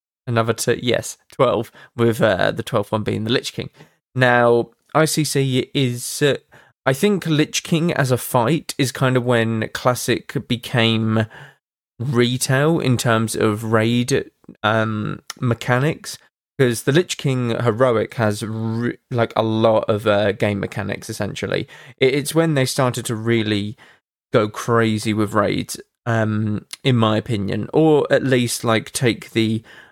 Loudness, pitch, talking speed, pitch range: -19 LUFS, 120 Hz, 145 wpm, 110-130 Hz